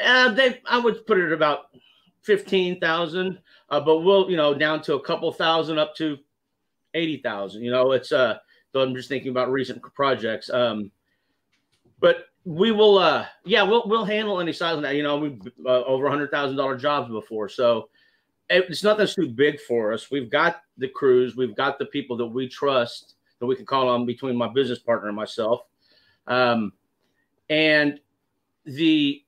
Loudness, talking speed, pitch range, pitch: -22 LUFS, 180 wpm, 125-180 Hz, 145 Hz